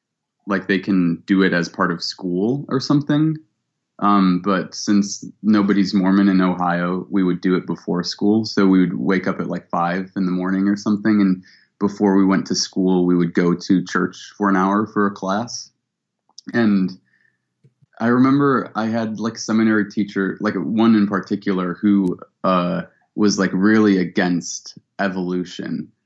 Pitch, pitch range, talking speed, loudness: 100 Hz, 90-110 Hz, 170 wpm, -19 LUFS